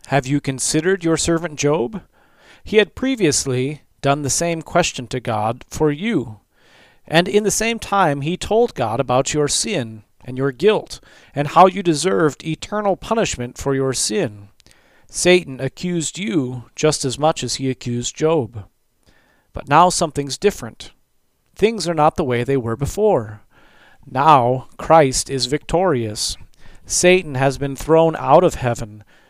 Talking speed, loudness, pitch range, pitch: 150 wpm, -18 LUFS, 125-175 Hz, 145 Hz